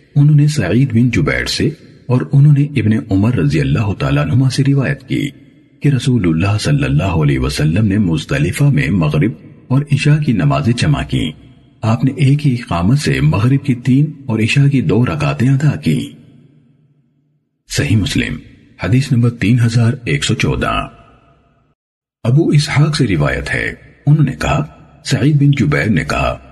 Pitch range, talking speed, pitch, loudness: 125-145 Hz, 165 wpm, 135 Hz, -14 LUFS